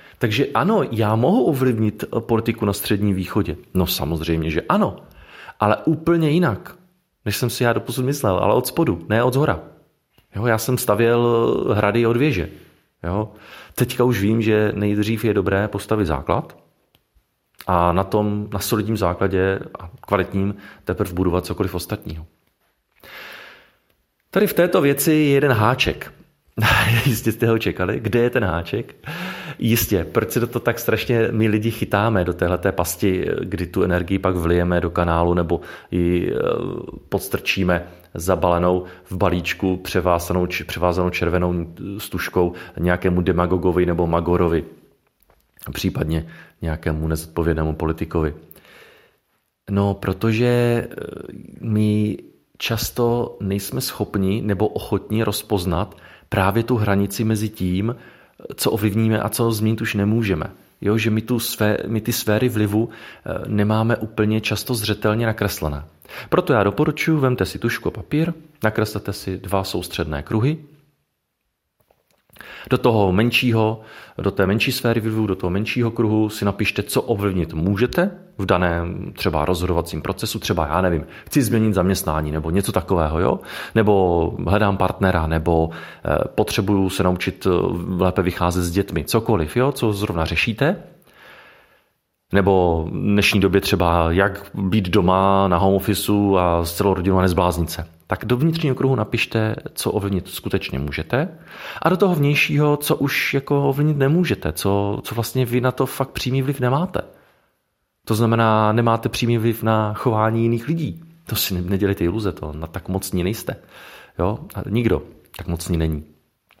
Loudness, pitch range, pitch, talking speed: -20 LUFS, 90-115 Hz, 100 Hz, 140 wpm